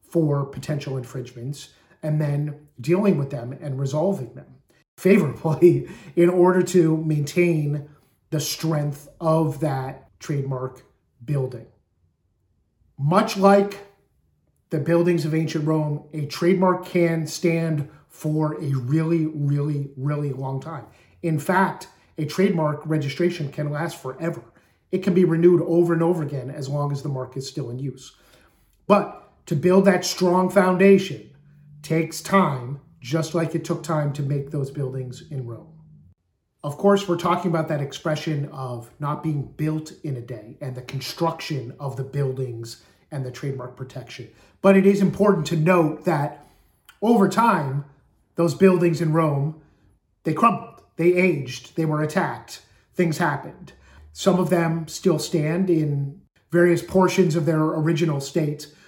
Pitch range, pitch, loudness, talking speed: 140-170 Hz, 155 Hz, -22 LUFS, 145 wpm